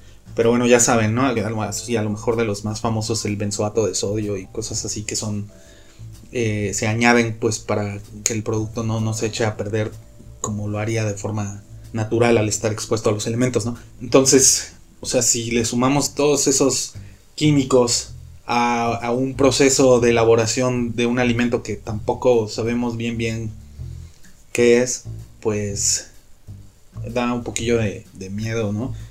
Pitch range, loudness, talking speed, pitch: 105-120 Hz, -20 LUFS, 165 wpm, 115 Hz